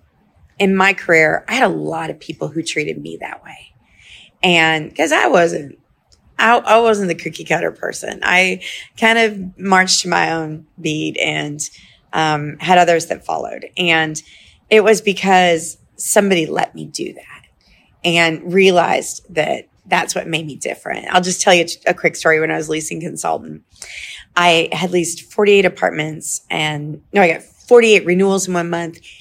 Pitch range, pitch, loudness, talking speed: 160-190 Hz, 170 Hz, -15 LUFS, 170 wpm